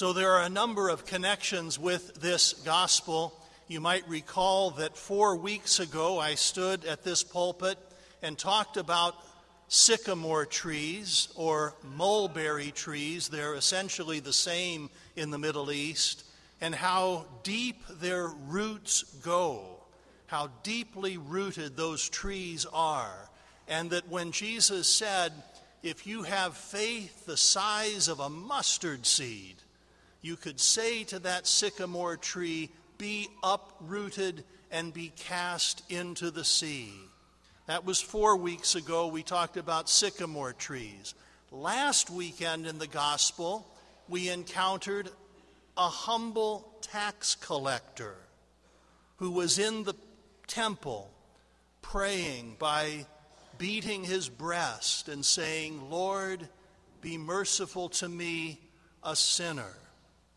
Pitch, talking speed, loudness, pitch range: 175 Hz, 120 wpm, -30 LUFS, 160-190 Hz